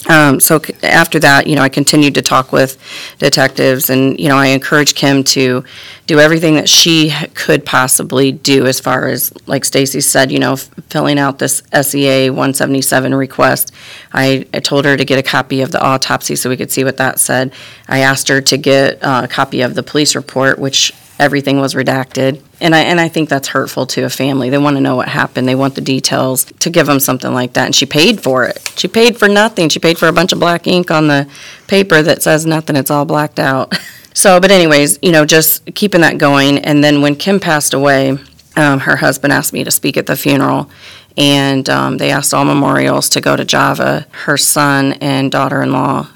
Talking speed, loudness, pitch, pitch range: 220 wpm, -11 LUFS, 140 Hz, 130-150 Hz